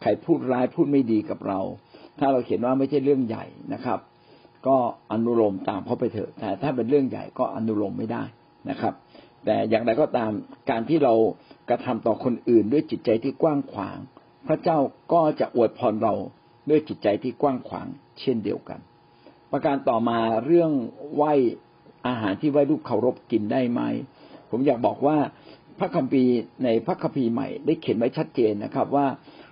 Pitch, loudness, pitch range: 135 Hz, -24 LUFS, 115-145 Hz